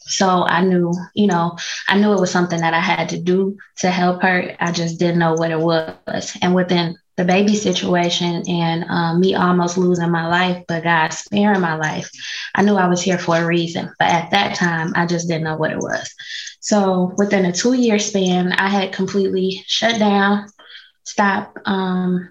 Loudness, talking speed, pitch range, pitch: -18 LUFS, 200 wpm, 170-195 Hz, 180 Hz